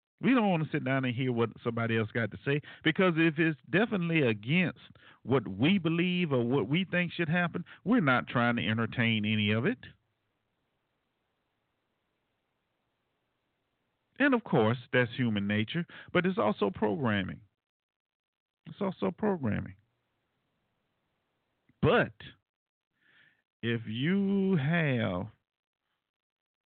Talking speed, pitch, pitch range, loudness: 120 wpm, 135 Hz, 115-175 Hz, -29 LUFS